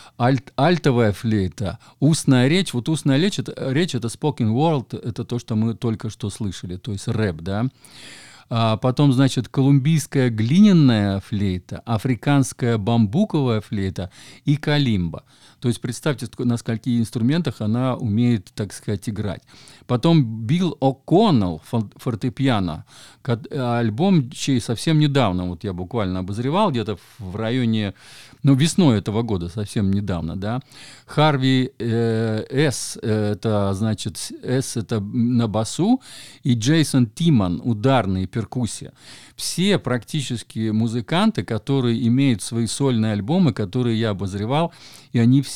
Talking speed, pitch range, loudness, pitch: 130 wpm, 110-135 Hz, -21 LUFS, 120 Hz